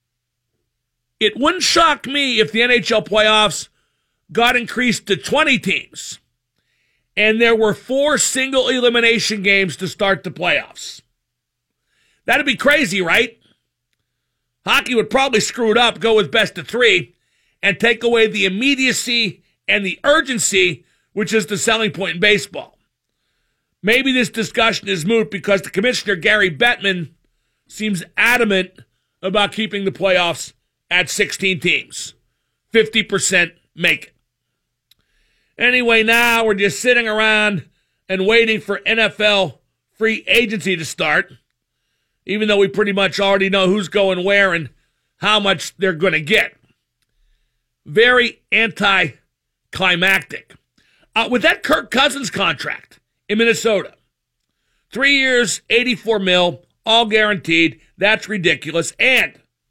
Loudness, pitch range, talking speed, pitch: -15 LUFS, 185-230 Hz, 125 wpm, 210 Hz